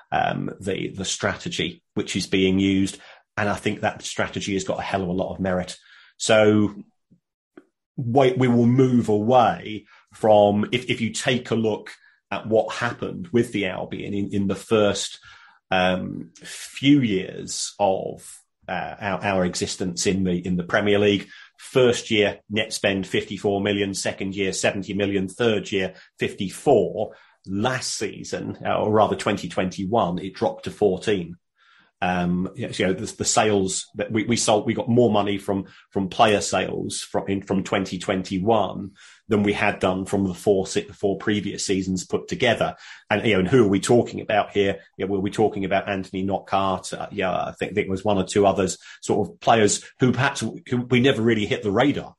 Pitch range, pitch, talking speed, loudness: 95-110 Hz, 100 Hz, 190 wpm, -23 LUFS